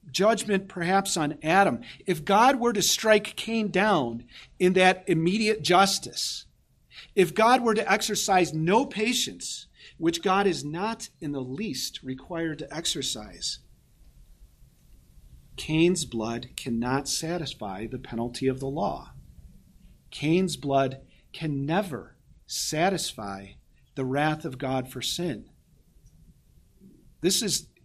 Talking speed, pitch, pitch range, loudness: 115 wpm, 160 Hz, 130-195 Hz, -26 LUFS